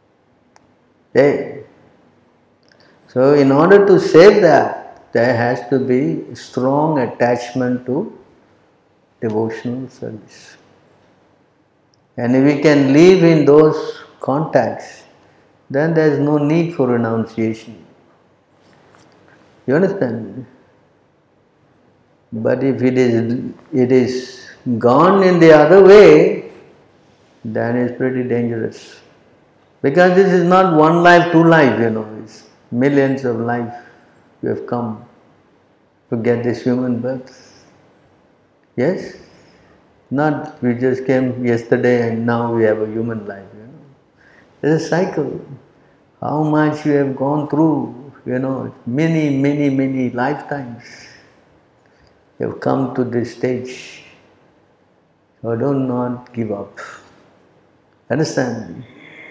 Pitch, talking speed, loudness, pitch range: 130 Hz, 115 wpm, -15 LUFS, 120-150 Hz